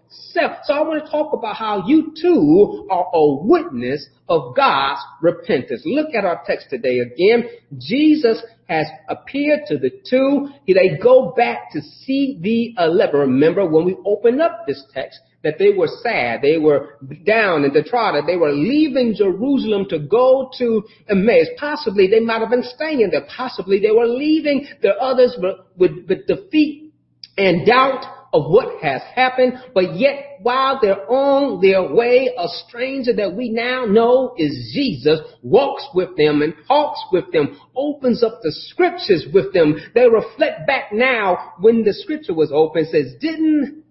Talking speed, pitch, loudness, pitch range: 165 wpm, 250 Hz, -17 LUFS, 195-295 Hz